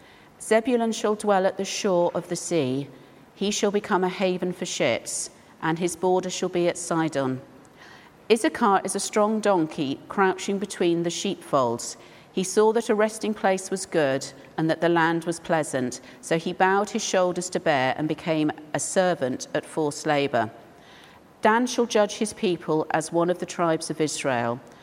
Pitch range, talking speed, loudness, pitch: 160-200 Hz, 175 wpm, -25 LUFS, 180 Hz